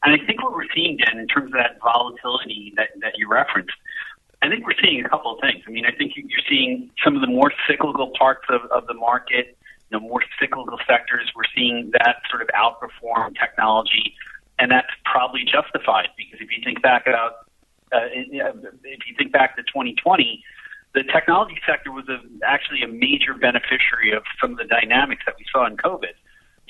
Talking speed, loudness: 195 wpm, -19 LUFS